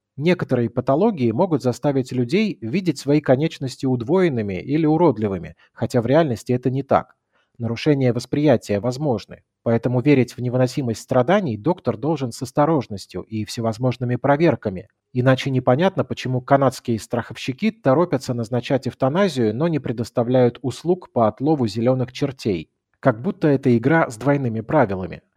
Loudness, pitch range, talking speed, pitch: -20 LUFS, 120-150 Hz, 130 wpm, 130 Hz